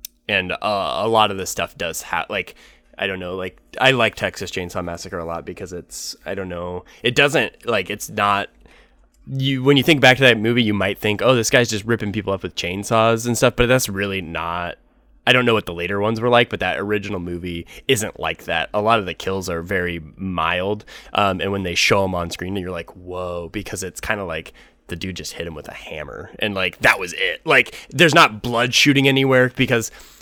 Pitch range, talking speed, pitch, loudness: 90-115 Hz, 230 wpm, 100 Hz, -19 LUFS